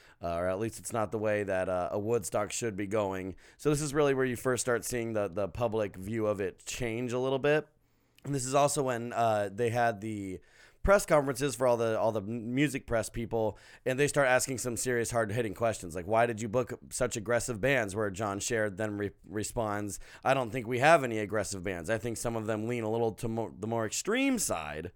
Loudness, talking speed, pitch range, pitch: -31 LUFS, 235 wpm, 105-125 Hz, 115 Hz